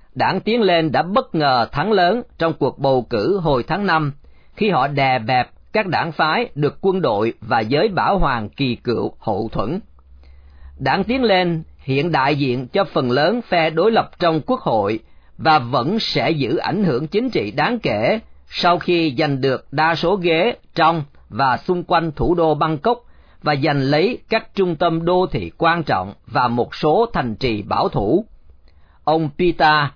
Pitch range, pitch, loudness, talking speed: 135-180 Hz, 160 Hz, -18 LUFS, 180 wpm